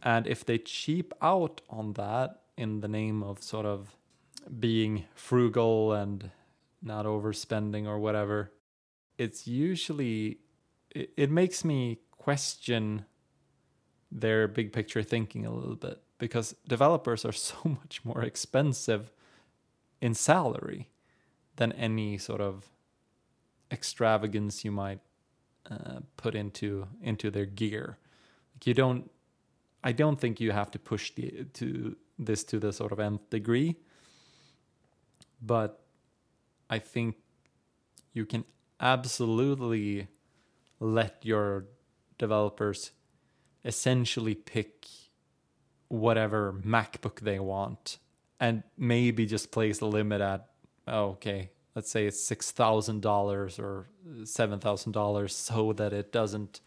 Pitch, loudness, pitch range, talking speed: 110 Hz, -31 LUFS, 105-120 Hz, 120 wpm